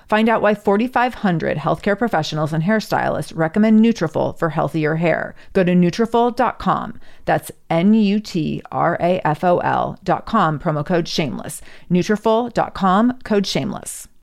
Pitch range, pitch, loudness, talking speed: 165-220 Hz, 190 Hz, -18 LUFS, 100 wpm